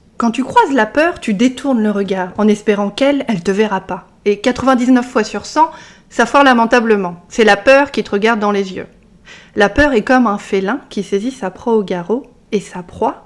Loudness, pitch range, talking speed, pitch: -14 LUFS, 200-255 Hz, 215 wpm, 215 Hz